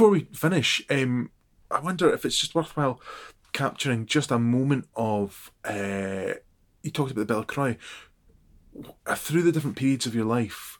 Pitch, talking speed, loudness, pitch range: 125 Hz, 160 wpm, -26 LUFS, 110-145 Hz